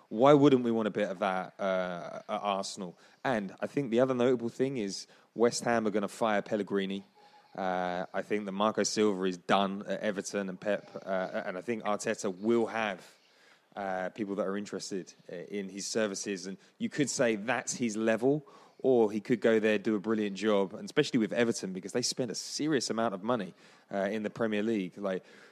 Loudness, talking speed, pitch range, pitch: -31 LUFS, 205 wpm, 95-115 Hz, 105 Hz